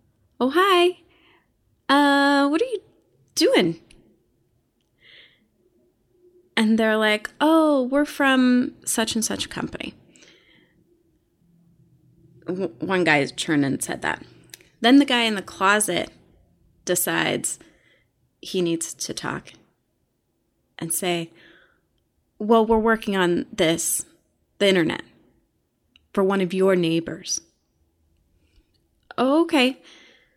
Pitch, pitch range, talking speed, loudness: 210 Hz, 165-275 Hz, 95 wpm, -21 LUFS